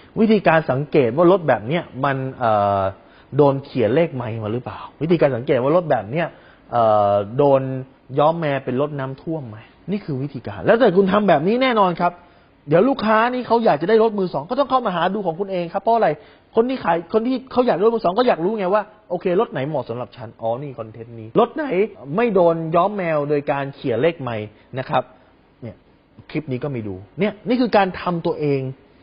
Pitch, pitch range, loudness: 160 Hz, 130-205 Hz, -19 LUFS